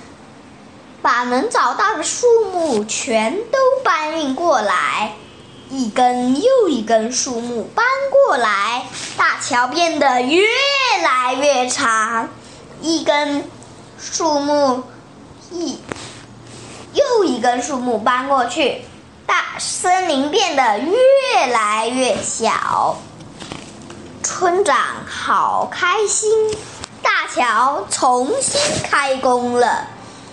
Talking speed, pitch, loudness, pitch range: 130 characters per minute, 280 Hz, -16 LUFS, 250-355 Hz